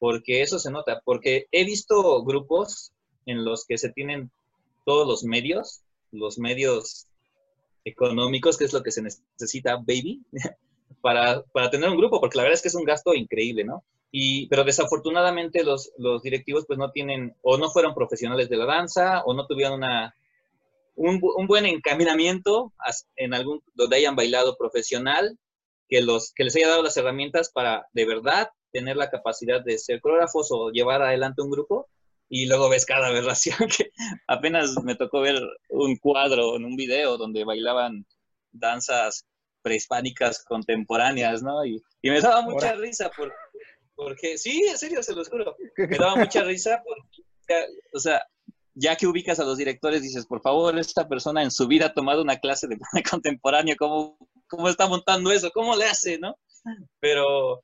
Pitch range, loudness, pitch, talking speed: 130-215 Hz, -23 LUFS, 155 Hz, 170 wpm